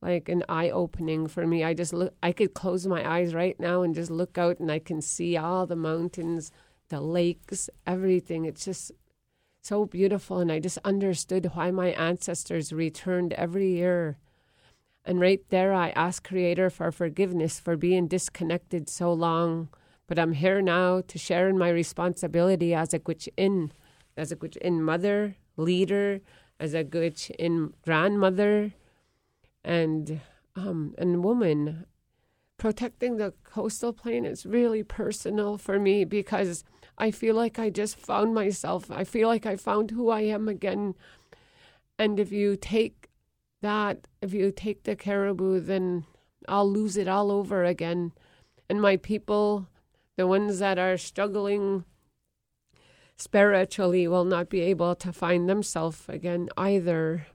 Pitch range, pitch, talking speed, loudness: 170-200 Hz, 180 Hz, 150 wpm, -27 LUFS